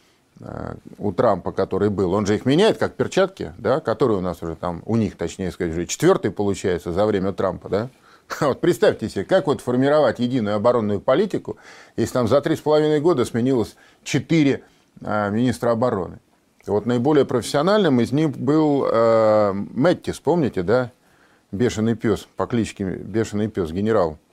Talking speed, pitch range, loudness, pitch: 160 wpm, 100-135 Hz, -21 LUFS, 115 Hz